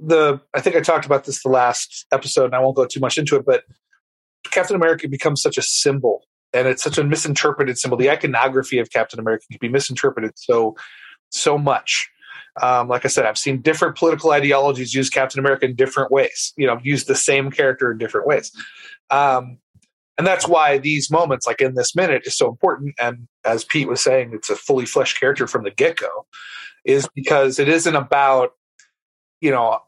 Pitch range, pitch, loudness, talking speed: 130-165 Hz, 140 Hz, -18 LUFS, 200 wpm